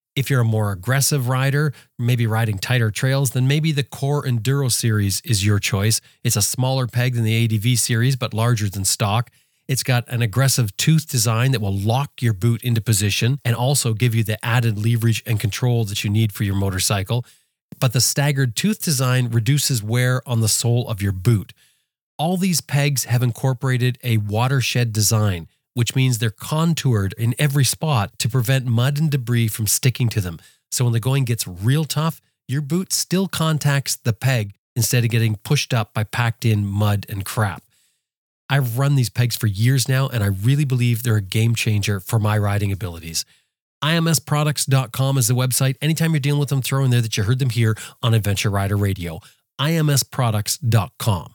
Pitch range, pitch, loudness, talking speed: 110-135 Hz, 120 Hz, -20 LUFS, 190 wpm